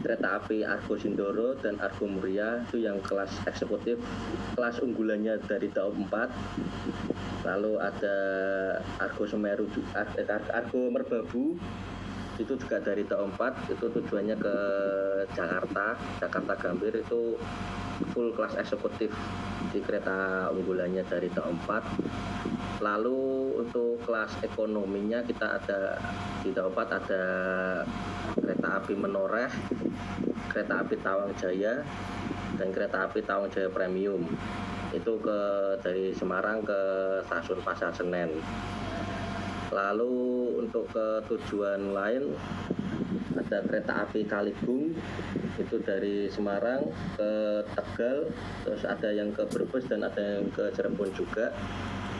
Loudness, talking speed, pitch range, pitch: -31 LUFS, 115 wpm, 95-110 Hz, 100 Hz